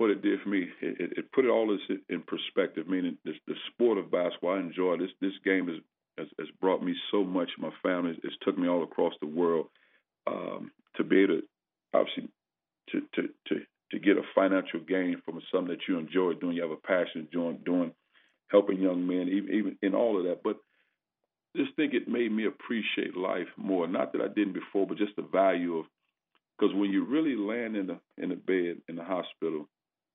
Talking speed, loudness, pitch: 215 wpm, -30 LUFS, 100 Hz